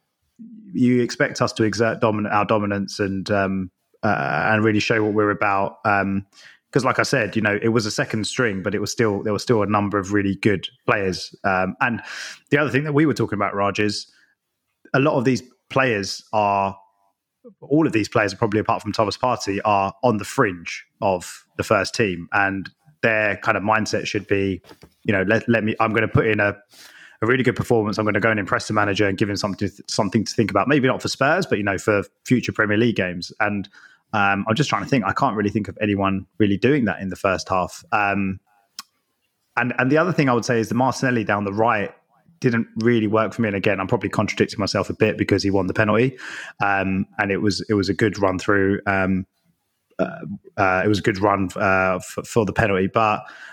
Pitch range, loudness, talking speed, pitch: 100-115 Hz, -21 LUFS, 230 wpm, 105 Hz